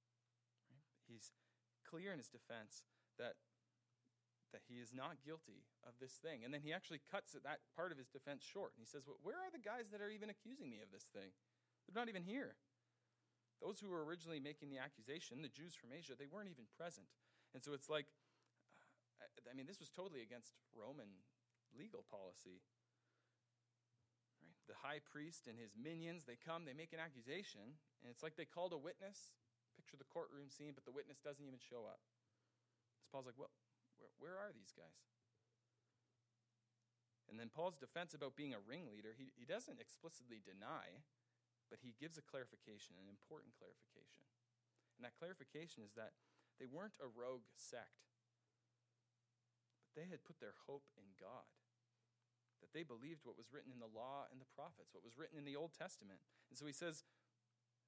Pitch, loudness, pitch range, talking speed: 125 Hz, -55 LUFS, 120-155 Hz, 180 wpm